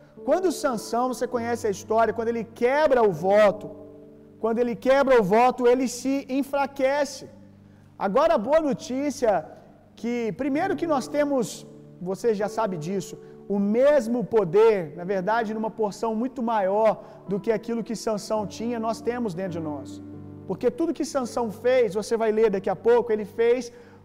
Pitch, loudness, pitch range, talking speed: 230 Hz, -24 LUFS, 210-255 Hz, 160 wpm